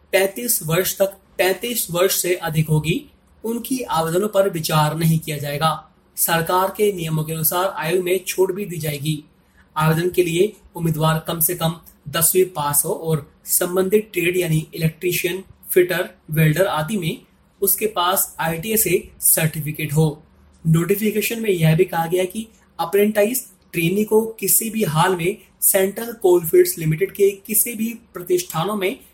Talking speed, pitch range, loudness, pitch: 150 wpm, 160-195 Hz, -19 LUFS, 180 Hz